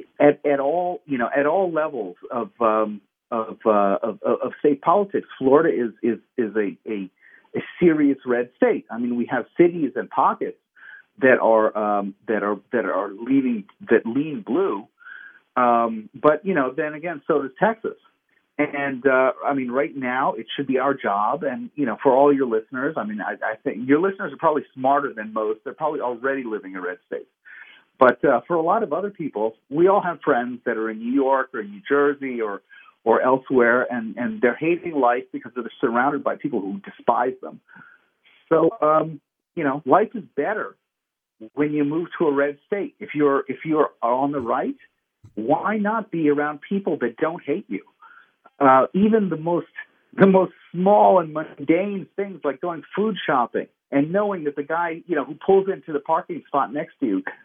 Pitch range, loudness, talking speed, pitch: 125-180 Hz, -22 LUFS, 195 wpm, 145 Hz